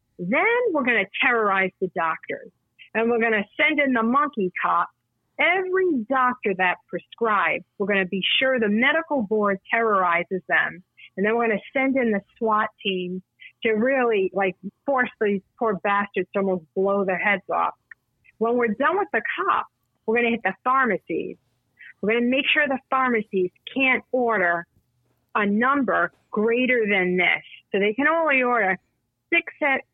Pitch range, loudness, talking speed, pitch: 190-260 Hz, -22 LUFS, 170 wpm, 220 Hz